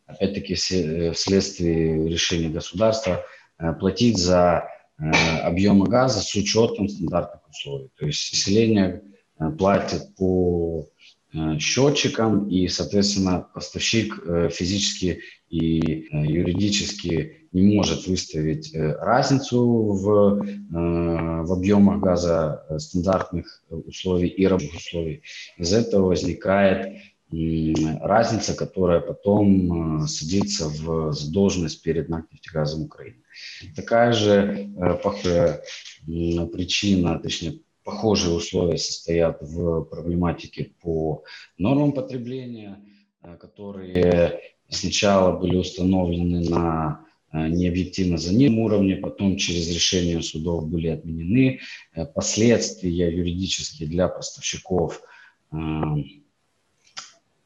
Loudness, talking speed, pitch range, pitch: -22 LUFS, 90 wpm, 80-100 Hz, 90 Hz